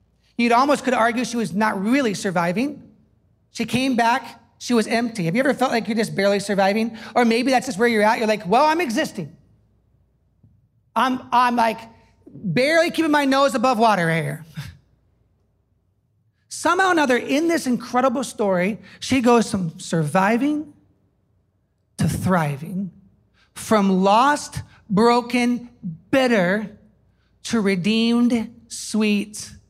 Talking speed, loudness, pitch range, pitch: 135 wpm, -20 LUFS, 180-245 Hz, 225 Hz